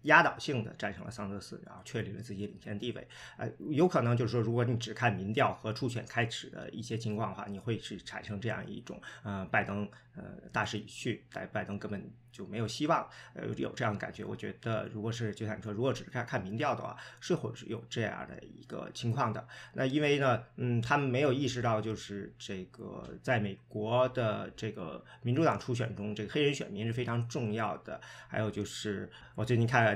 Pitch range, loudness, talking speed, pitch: 105-125 Hz, -34 LUFS, 320 characters per minute, 115 Hz